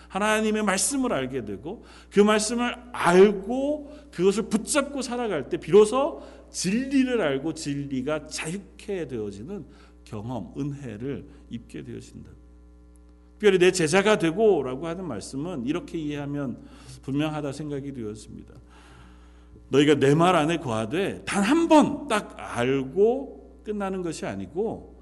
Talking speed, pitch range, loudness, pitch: 275 characters per minute, 130-215 Hz, -24 LUFS, 160 Hz